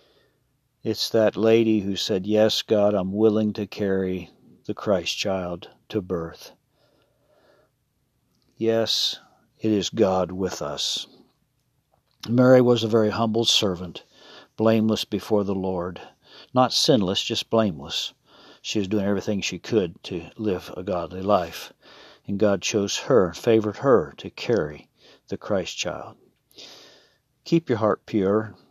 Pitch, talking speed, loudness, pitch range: 105 Hz, 130 wpm, -23 LUFS, 95-115 Hz